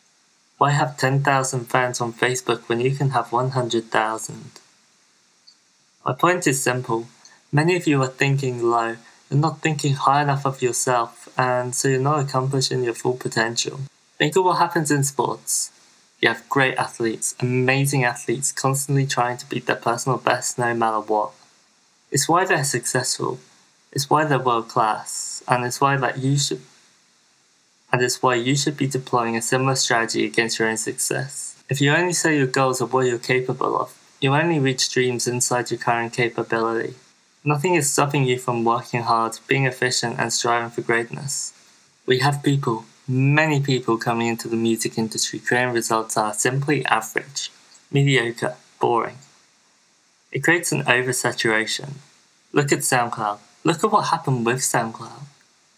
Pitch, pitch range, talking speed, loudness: 125 Hz, 115-140 Hz, 165 wpm, -21 LUFS